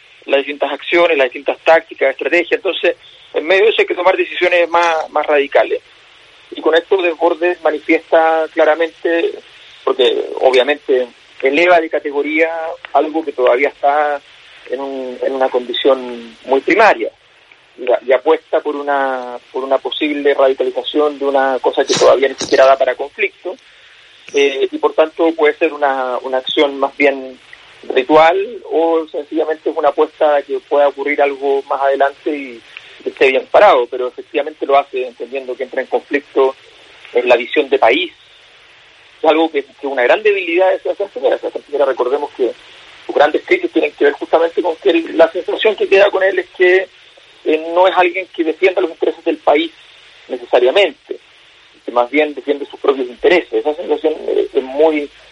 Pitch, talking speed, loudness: 160 Hz, 170 wpm, -14 LUFS